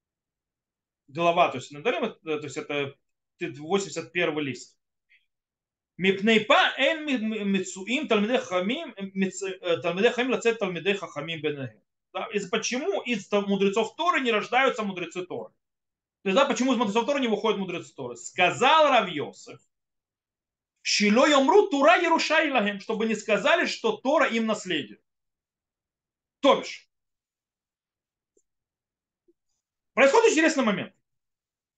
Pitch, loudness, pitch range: 210 Hz, -24 LUFS, 175-255 Hz